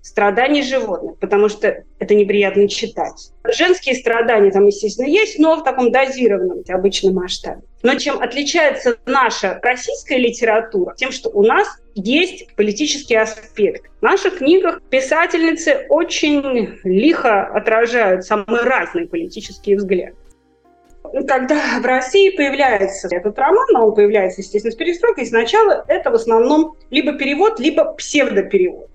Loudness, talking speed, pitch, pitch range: -16 LUFS, 130 wpm, 265 Hz, 215-330 Hz